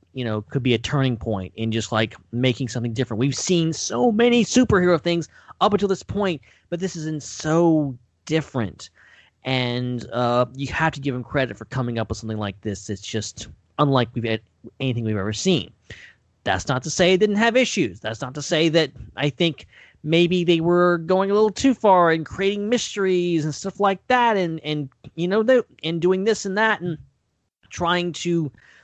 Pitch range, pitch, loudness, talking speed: 120-180 Hz, 150 Hz, -22 LUFS, 200 wpm